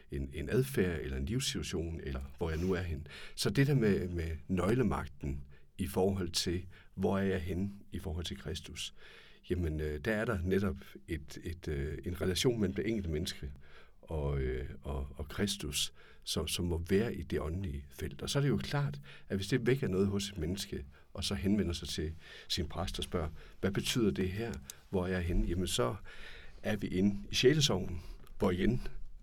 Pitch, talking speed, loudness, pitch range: 90 Hz, 195 wpm, -35 LUFS, 75-100 Hz